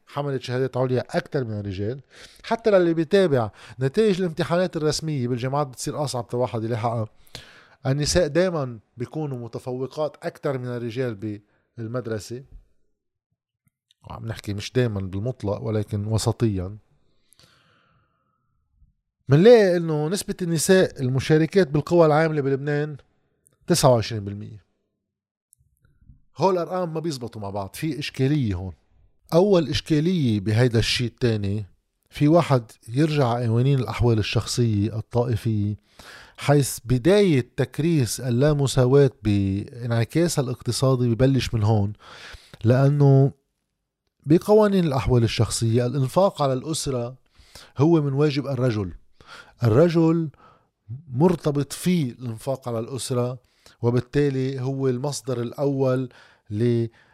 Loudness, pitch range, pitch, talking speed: -22 LUFS, 115-150 Hz, 130 Hz, 100 wpm